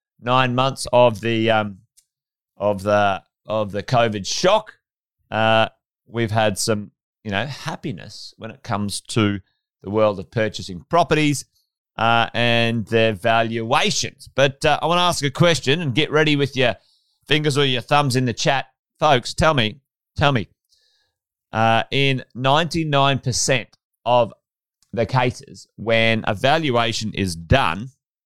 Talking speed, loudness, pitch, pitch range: 140 wpm, -19 LUFS, 120 Hz, 110-140 Hz